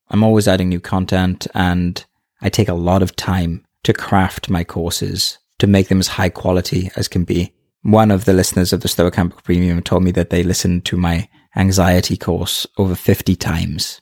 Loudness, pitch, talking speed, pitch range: -16 LUFS, 90 Hz, 195 wpm, 90-95 Hz